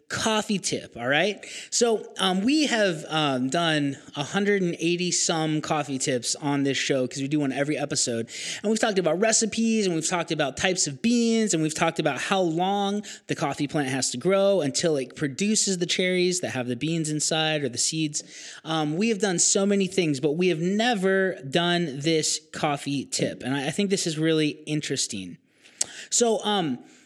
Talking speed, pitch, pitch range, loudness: 190 wpm, 165 Hz, 150-200 Hz, -24 LUFS